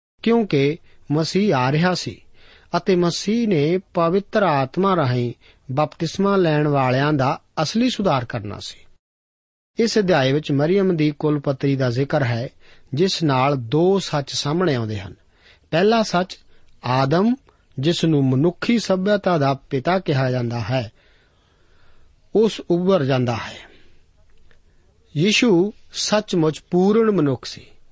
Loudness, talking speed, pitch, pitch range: -20 LUFS, 125 wpm, 150 Hz, 120-185 Hz